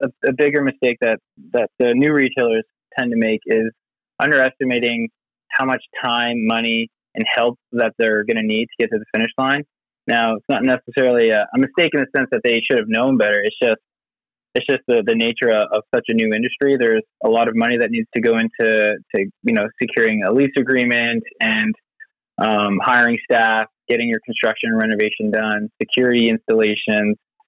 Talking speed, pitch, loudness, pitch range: 195 wpm, 115 Hz, -18 LUFS, 110-130 Hz